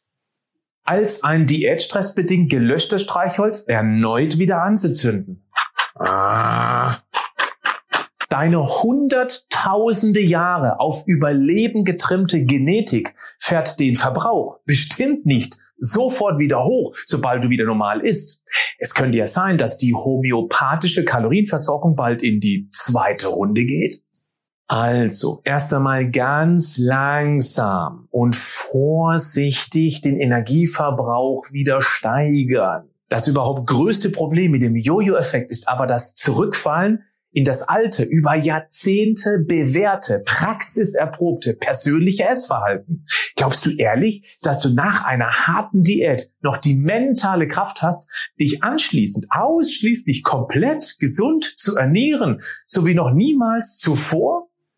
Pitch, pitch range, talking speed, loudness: 155 Hz, 130-195 Hz, 110 wpm, -17 LUFS